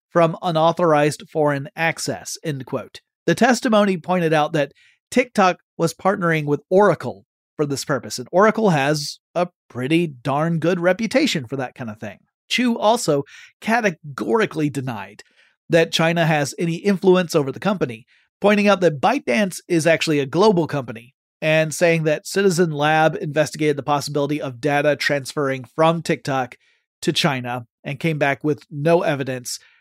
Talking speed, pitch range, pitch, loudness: 150 wpm, 145-180 Hz, 155 Hz, -20 LUFS